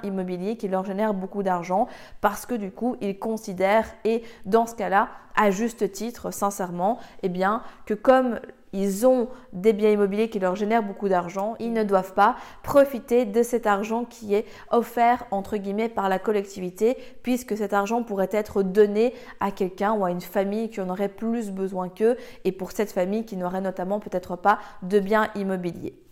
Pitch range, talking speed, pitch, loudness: 195-230 Hz, 185 wpm, 210 Hz, -25 LUFS